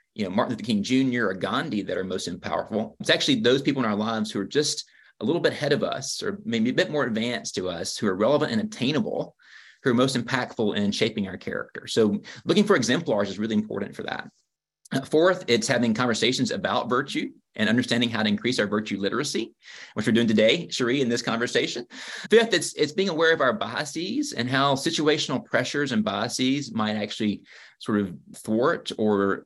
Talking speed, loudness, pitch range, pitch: 205 wpm, -25 LUFS, 110-180 Hz, 135 Hz